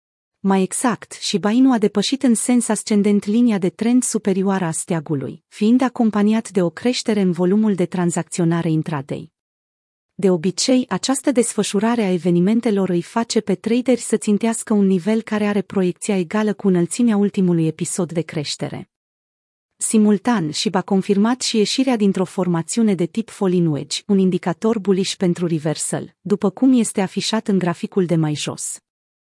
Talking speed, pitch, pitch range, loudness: 155 wpm, 200 Hz, 175-220 Hz, -19 LUFS